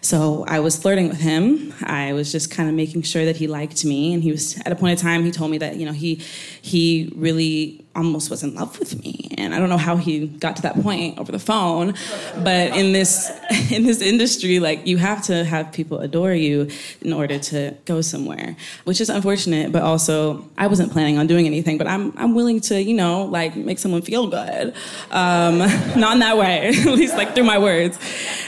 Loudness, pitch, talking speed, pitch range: -19 LUFS, 170 Hz, 225 wpm, 160-195 Hz